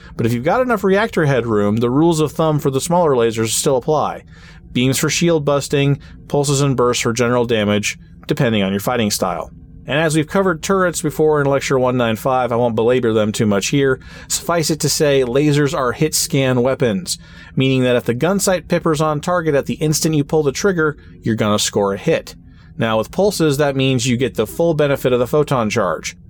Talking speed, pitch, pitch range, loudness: 210 wpm, 140 Hz, 120-160 Hz, -17 LUFS